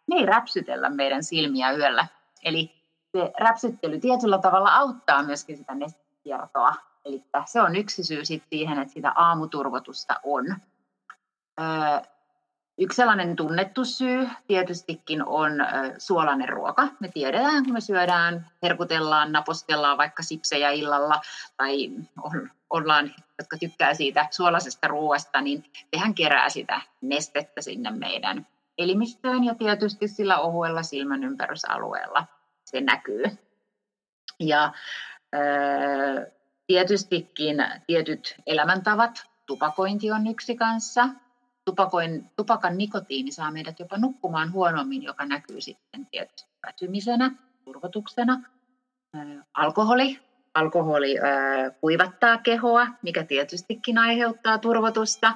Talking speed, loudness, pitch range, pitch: 105 wpm, -24 LUFS, 150-230 Hz, 170 Hz